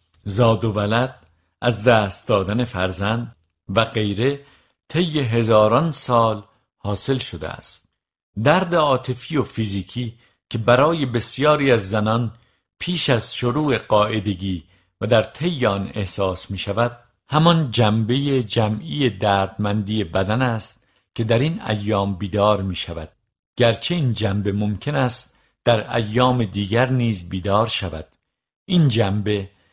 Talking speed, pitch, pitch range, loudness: 125 wpm, 110 Hz, 100-125 Hz, -20 LUFS